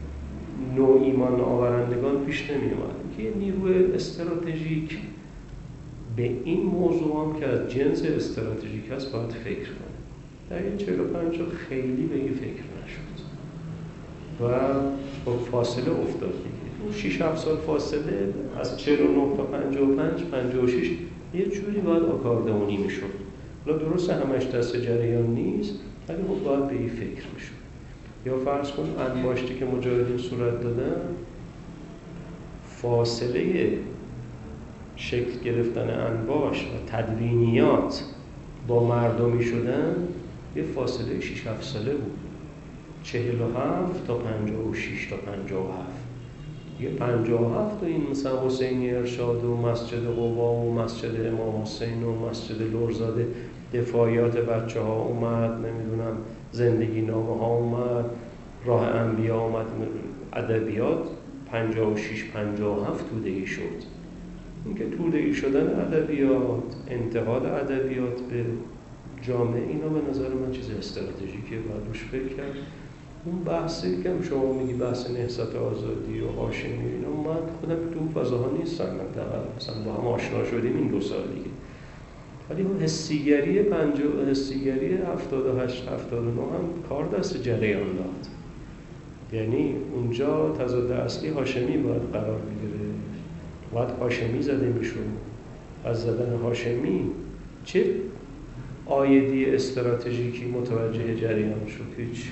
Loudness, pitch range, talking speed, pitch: -27 LUFS, 115-140 Hz, 125 wpm, 125 Hz